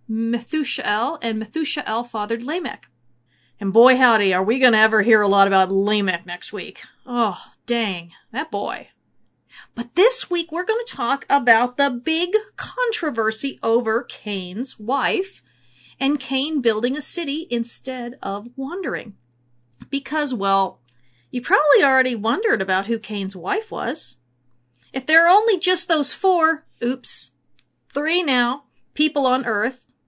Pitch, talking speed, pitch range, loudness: 240 Hz, 140 wpm, 205-295 Hz, -20 LUFS